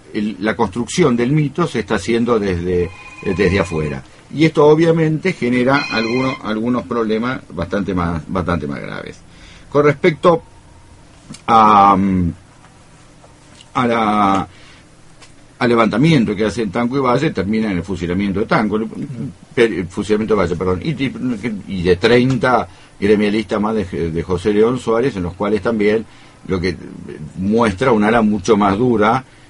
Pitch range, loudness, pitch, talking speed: 95-125 Hz, -16 LUFS, 110 Hz, 140 wpm